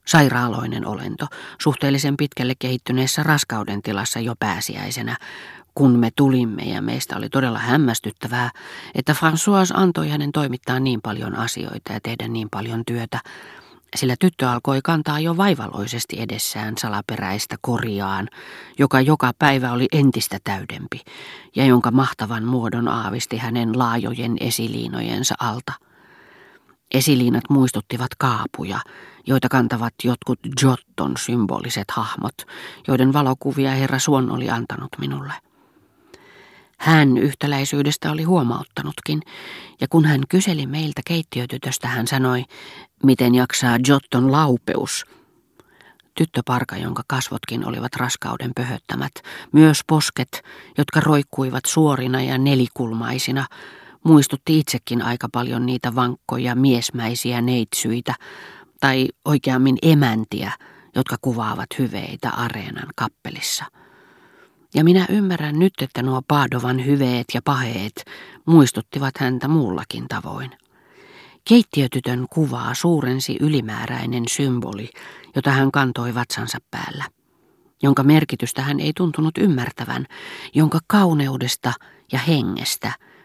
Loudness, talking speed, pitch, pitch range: -20 LUFS, 105 wpm, 130 Hz, 120-145 Hz